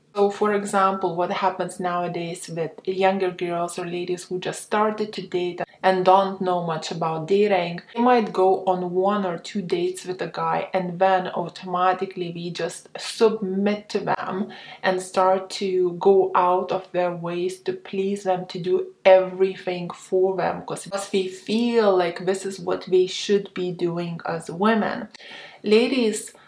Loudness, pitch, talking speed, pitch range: -23 LUFS, 185 Hz, 160 wpm, 180-195 Hz